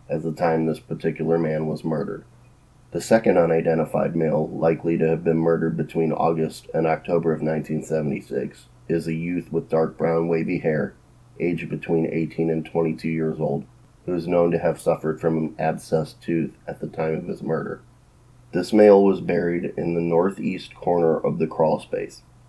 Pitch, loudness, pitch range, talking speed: 80 Hz, -23 LUFS, 80-85 Hz, 175 wpm